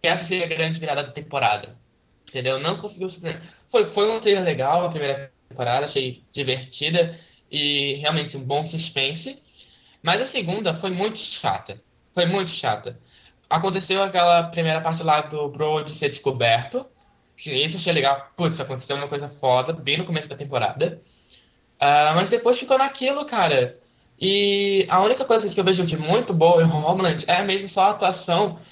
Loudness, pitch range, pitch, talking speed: -21 LUFS, 145-190 Hz, 165 Hz, 170 wpm